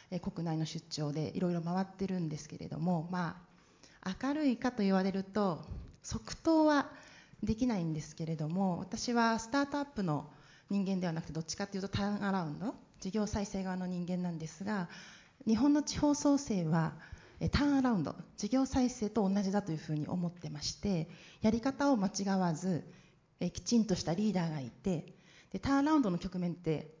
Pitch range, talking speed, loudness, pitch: 165-220 Hz, 365 characters per minute, -34 LUFS, 190 Hz